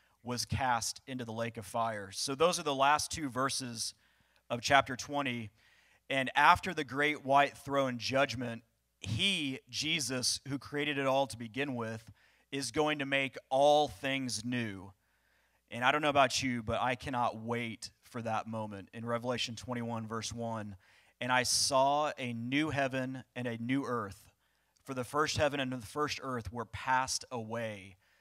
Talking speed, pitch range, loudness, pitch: 170 wpm, 115-140 Hz, -33 LUFS, 125 Hz